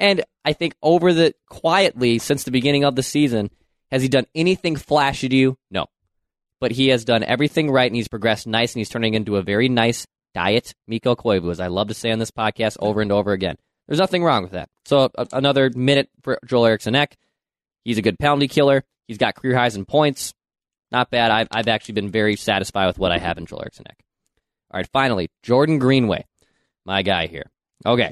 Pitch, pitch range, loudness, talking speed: 120 Hz, 110-140 Hz, -20 LUFS, 215 wpm